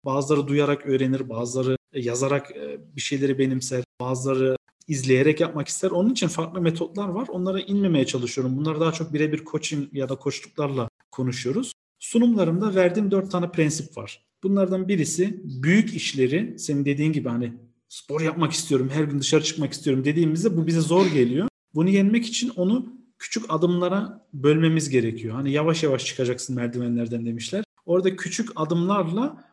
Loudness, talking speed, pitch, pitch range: -24 LUFS, 150 wpm, 155 Hz, 130-185 Hz